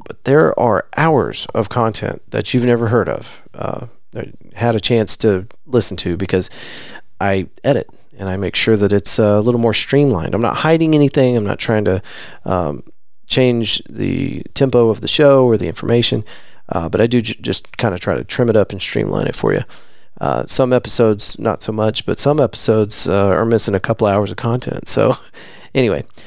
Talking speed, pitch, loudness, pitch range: 200 wpm, 115 Hz, -15 LUFS, 100-125 Hz